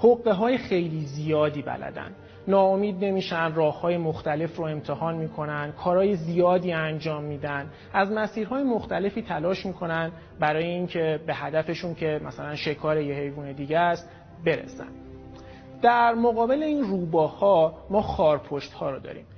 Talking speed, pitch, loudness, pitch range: 130 wpm, 165 Hz, -26 LUFS, 150-195 Hz